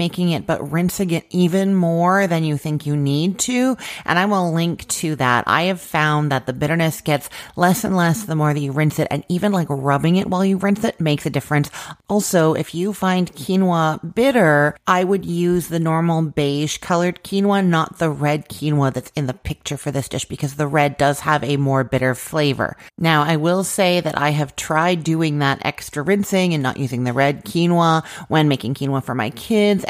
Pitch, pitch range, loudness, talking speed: 160 Hz, 145-180 Hz, -19 LUFS, 210 wpm